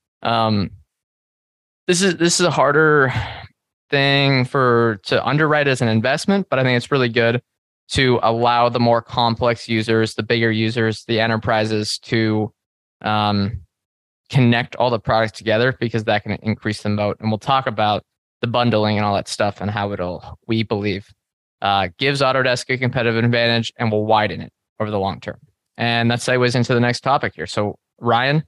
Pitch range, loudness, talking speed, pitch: 105-125 Hz, -18 LUFS, 175 wpm, 115 Hz